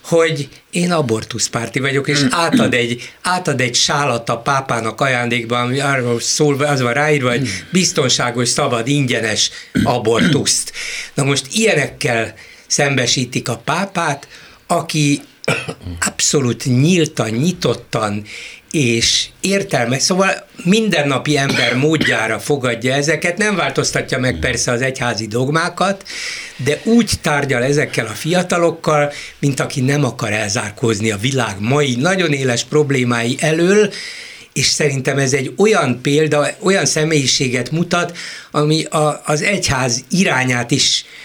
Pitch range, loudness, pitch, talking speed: 120-160 Hz, -16 LUFS, 145 Hz, 120 wpm